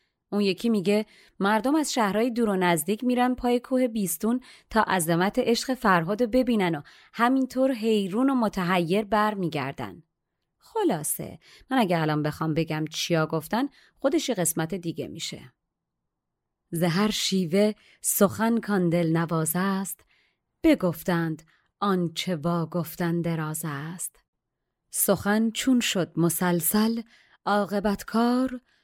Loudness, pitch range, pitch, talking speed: -25 LUFS, 170-235 Hz, 200 Hz, 115 wpm